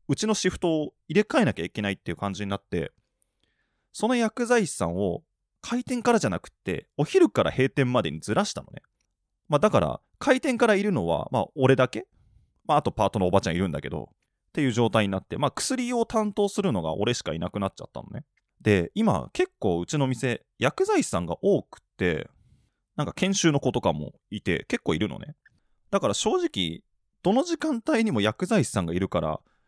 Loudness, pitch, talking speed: -26 LUFS, 165 Hz, 380 characters per minute